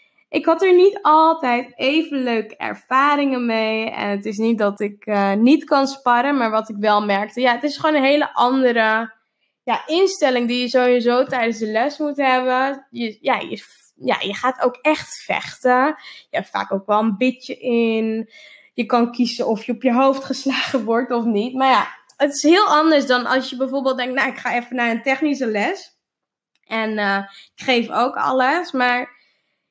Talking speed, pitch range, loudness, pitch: 195 wpm, 230-275 Hz, -19 LUFS, 250 Hz